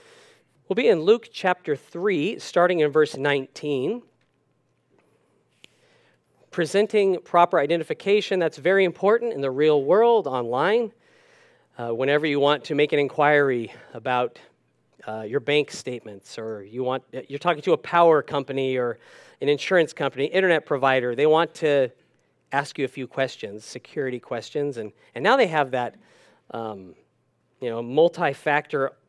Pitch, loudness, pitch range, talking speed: 145 Hz, -23 LUFS, 130-175 Hz, 140 wpm